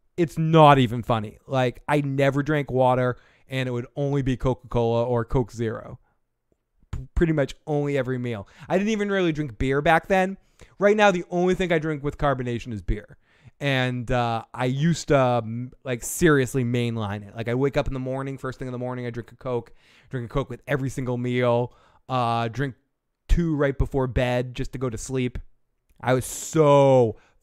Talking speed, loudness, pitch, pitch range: 195 wpm, -24 LUFS, 130 Hz, 120-145 Hz